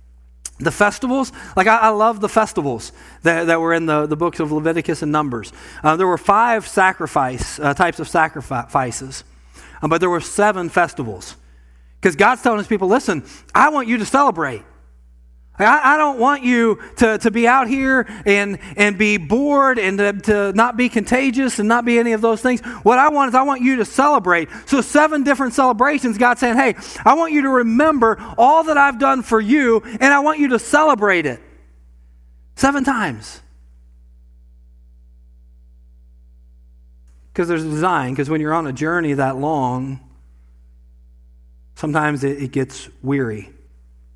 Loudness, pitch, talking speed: -16 LUFS, 175 Hz, 170 wpm